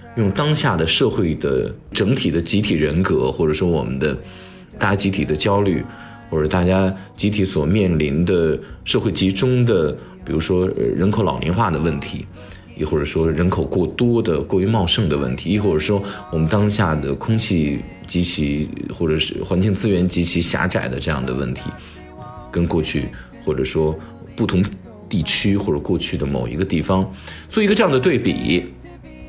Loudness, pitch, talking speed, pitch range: -19 LUFS, 90 Hz, 260 characters per minute, 80-100 Hz